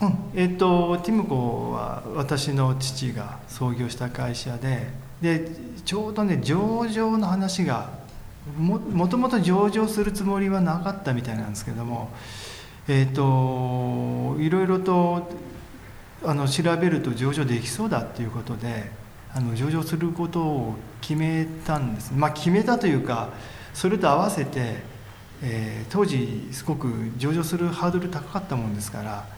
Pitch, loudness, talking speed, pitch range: 135 Hz, -25 LUFS, 290 characters per minute, 120-175 Hz